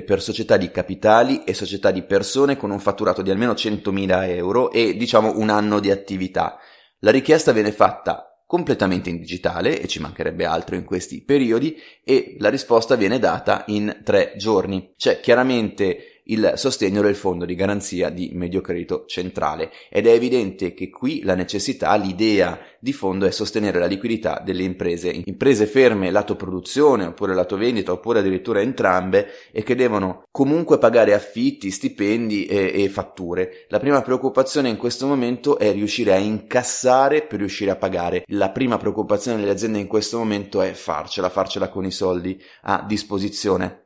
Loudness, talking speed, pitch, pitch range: -20 LUFS, 165 wpm, 105 Hz, 95-125 Hz